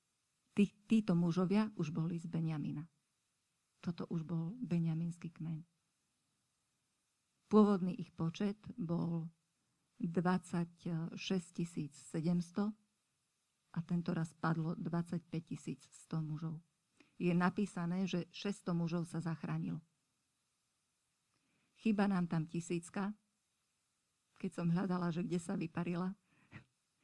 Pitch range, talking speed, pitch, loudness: 165-190 Hz, 95 wpm, 175 Hz, -39 LUFS